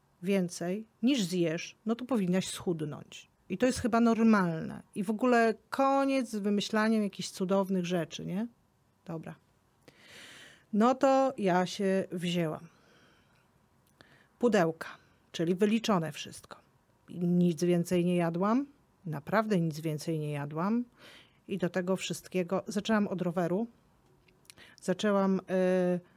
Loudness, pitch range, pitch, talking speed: -30 LUFS, 175-215 Hz, 190 Hz, 115 wpm